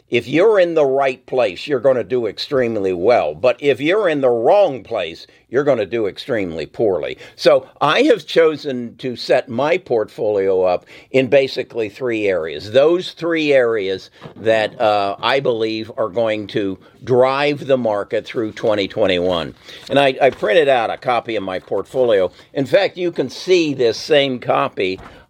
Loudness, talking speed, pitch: -17 LUFS, 170 wpm, 140 Hz